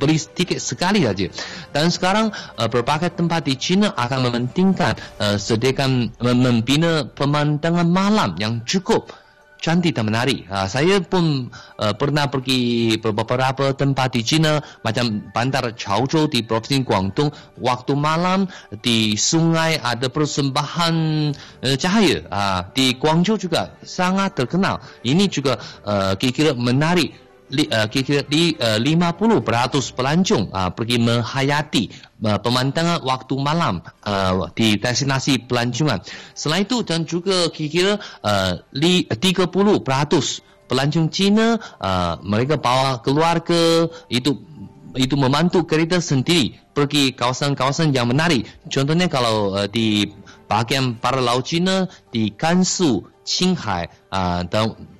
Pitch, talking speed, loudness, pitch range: 140 Hz, 110 wpm, -19 LUFS, 120-165 Hz